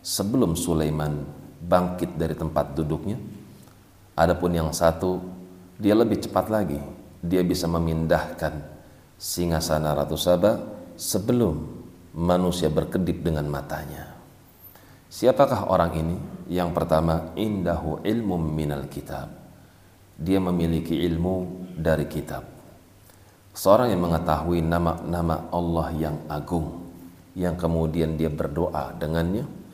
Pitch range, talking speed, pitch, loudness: 80-90 Hz, 100 wpm, 85 Hz, -25 LUFS